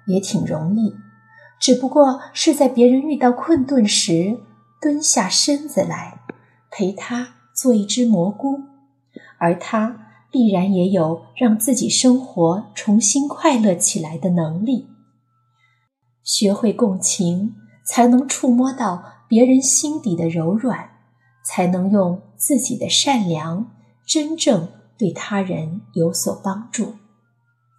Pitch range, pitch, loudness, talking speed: 170-255 Hz, 210 Hz, -18 LUFS, 175 characters per minute